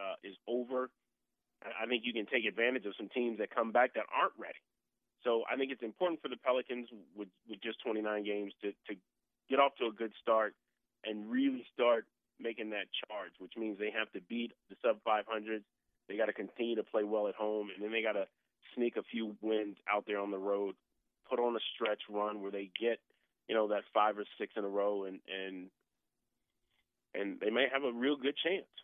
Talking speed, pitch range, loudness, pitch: 215 wpm, 105-120 Hz, -36 LUFS, 110 Hz